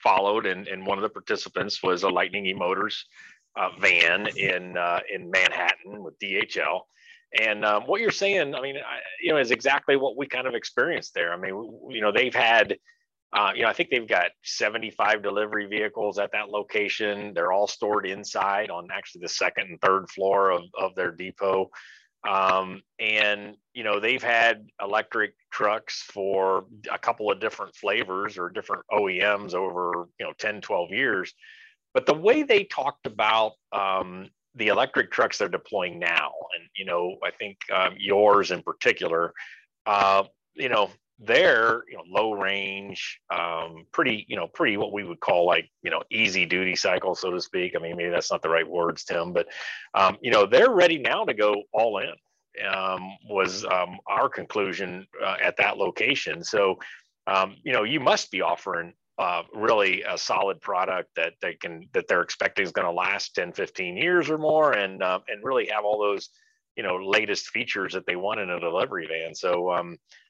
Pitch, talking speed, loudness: 105 Hz, 190 wpm, -25 LUFS